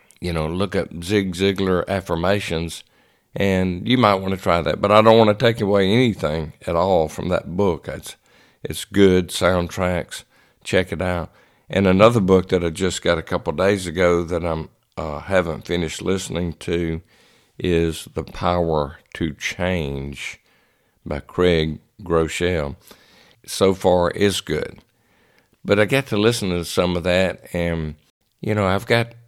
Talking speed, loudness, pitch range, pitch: 160 wpm, -20 LUFS, 85-100 Hz, 90 Hz